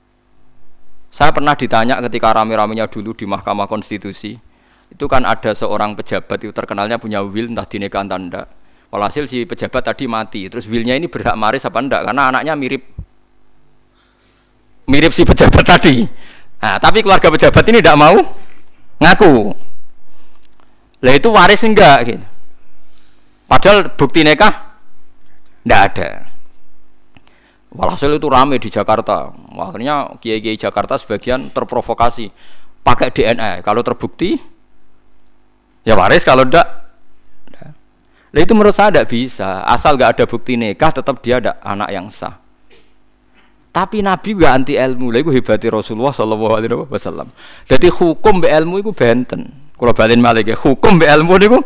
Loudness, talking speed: -12 LUFS, 135 wpm